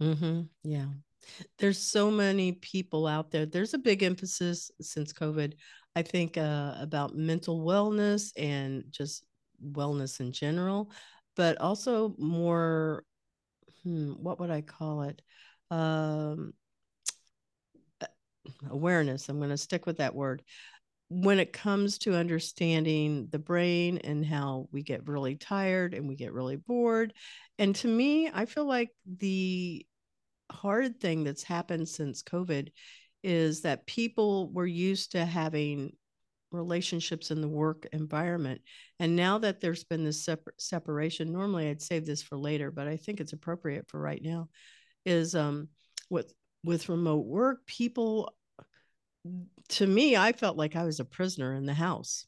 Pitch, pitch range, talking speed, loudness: 165 Hz, 150-190 Hz, 145 wpm, -31 LUFS